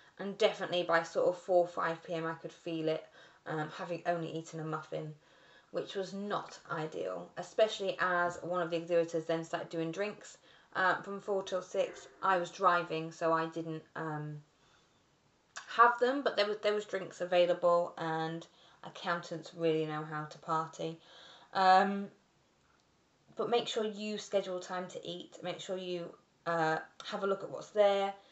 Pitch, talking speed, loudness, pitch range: 175 Hz, 165 wpm, -34 LUFS, 165-195 Hz